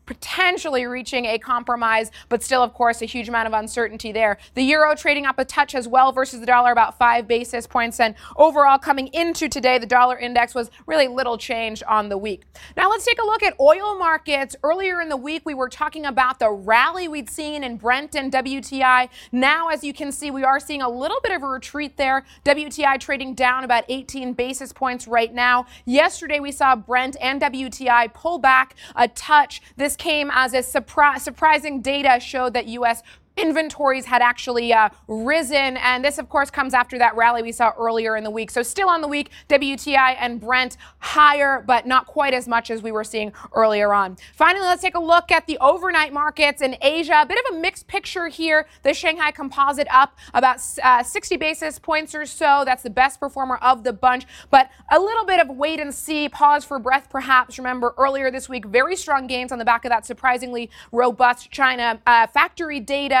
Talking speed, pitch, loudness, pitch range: 205 wpm, 265 Hz, -19 LUFS, 245-295 Hz